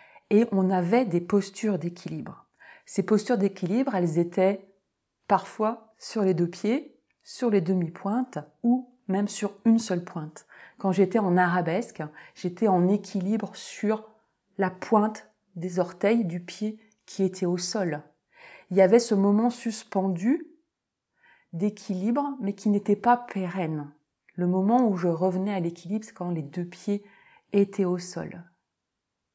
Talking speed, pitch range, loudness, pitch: 145 wpm, 180-220 Hz, -26 LUFS, 195 Hz